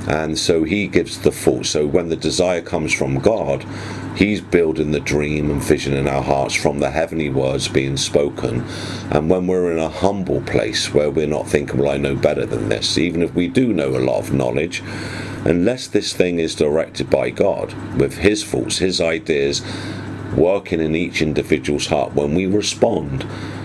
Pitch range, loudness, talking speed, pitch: 75-95 Hz, -19 LUFS, 190 wpm, 85 Hz